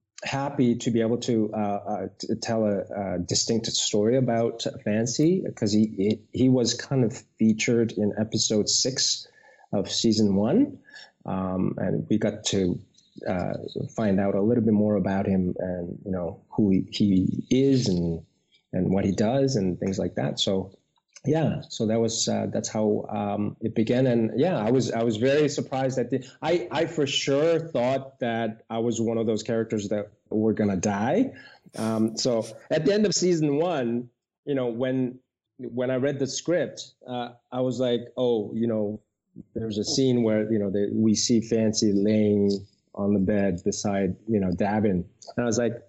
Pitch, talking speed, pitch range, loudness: 115 Hz, 180 wpm, 105-125 Hz, -25 LUFS